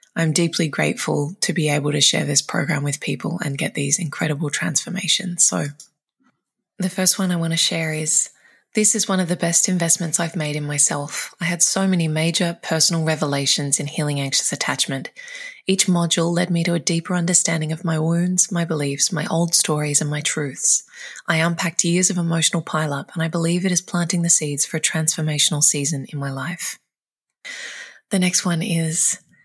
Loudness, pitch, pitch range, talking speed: -19 LUFS, 165 Hz, 155-180 Hz, 190 wpm